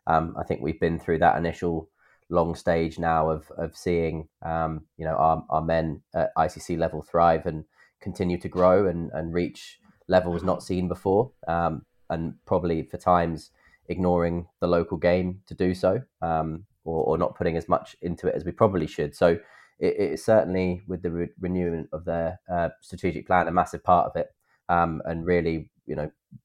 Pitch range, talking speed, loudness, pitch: 80-90 Hz, 190 wpm, -26 LUFS, 85 Hz